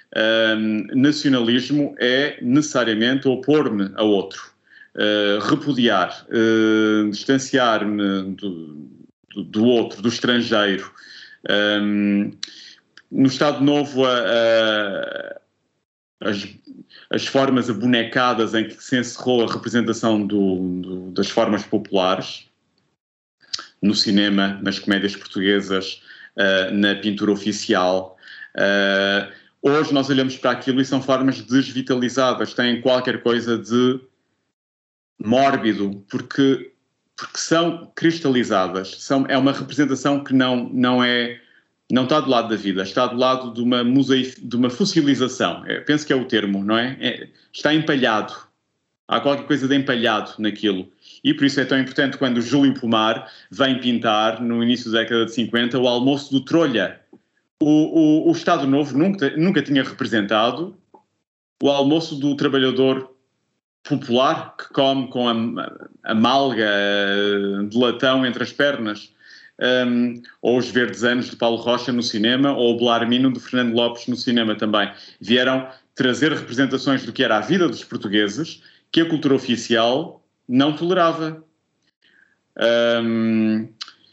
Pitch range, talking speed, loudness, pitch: 110-135 Hz, 135 wpm, -19 LUFS, 120 Hz